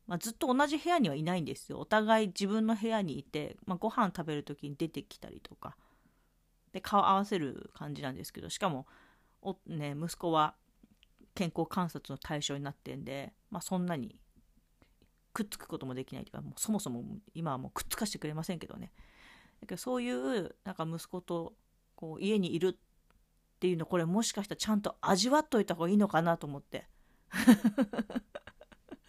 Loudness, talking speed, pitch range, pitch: -34 LUFS, 365 characters per minute, 155-215 Hz, 180 Hz